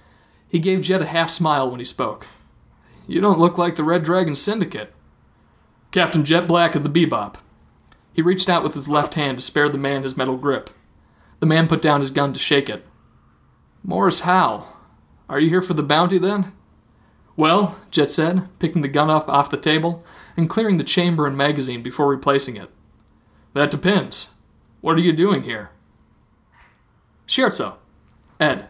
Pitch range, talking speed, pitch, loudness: 140-175 Hz, 175 wpm, 155 Hz, -19 LUFS